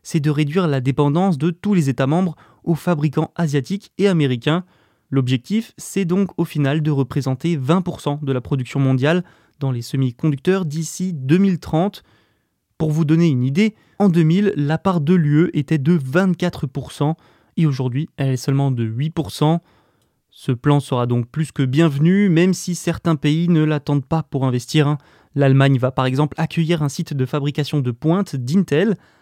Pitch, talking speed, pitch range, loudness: 155 Hz, 165 wpm, 140-175 Hz, -19 LUFS